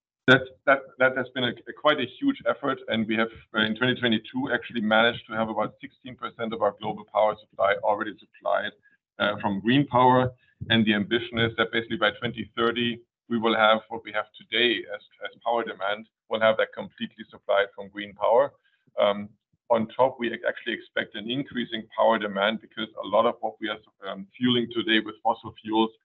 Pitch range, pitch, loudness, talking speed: 110-120 Hz, 115 Hz, -25 LUFS, 190 wpm